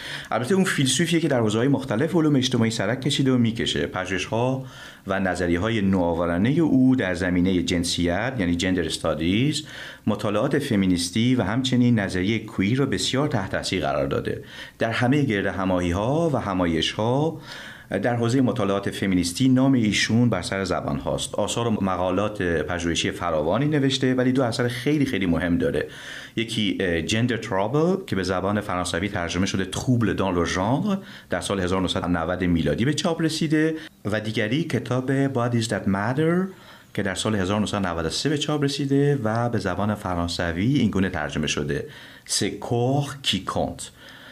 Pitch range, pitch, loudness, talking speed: 95-130 Hz, 110 Hz, -23 LUFS, 150 wpm